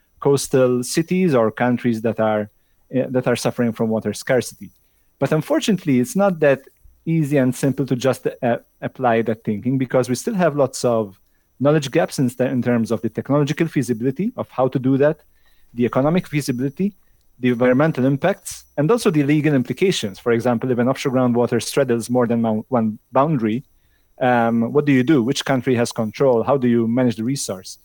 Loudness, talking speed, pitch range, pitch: -19 LUFS, 185 wpm, 115-145 Hz, 130 Hz